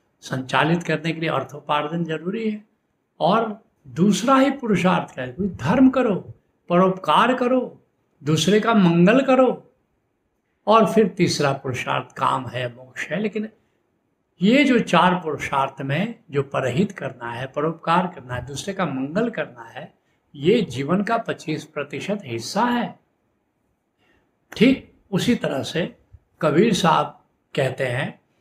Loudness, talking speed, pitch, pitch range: -21 LUFS, 130 wpm, 175 Hz, 140-220 Hz